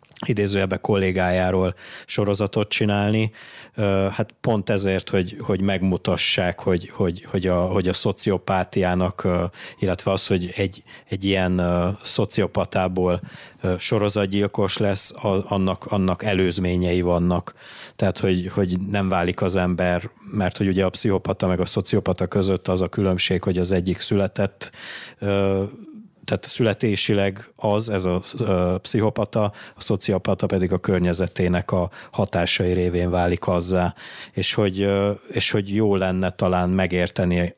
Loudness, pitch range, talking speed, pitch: -21 LUFS, 90-100 Hz, 125 wpm, 95 Hz